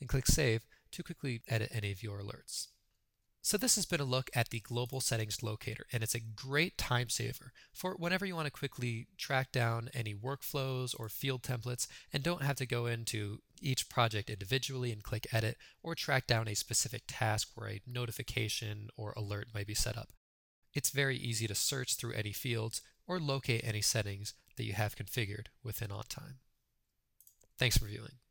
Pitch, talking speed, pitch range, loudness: 120 Hz, 185 wpm, 110-135 Hz, -36 LUFS